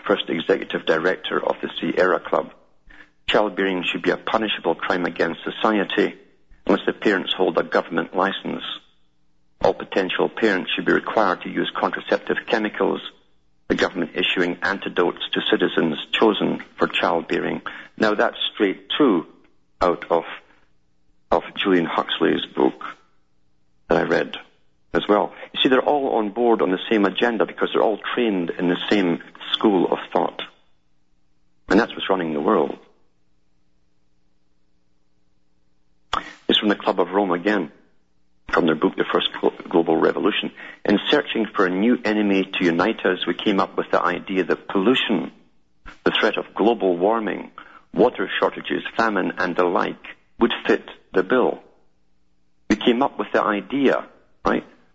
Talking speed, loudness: 145 wpm, -21 LUFS